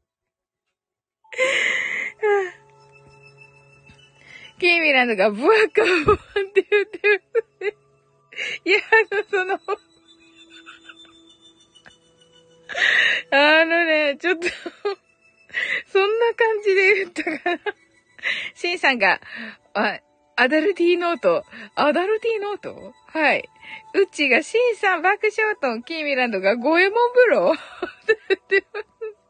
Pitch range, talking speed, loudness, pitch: 275-425 Hz, 210 characters per minute, -20 LUFS, 375 Hz